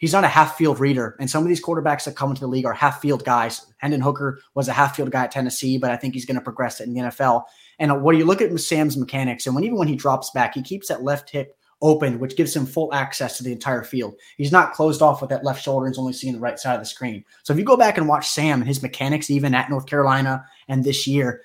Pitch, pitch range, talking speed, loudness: 140 Hz, 130-150 Hz, 285 wpm, -21 LUFS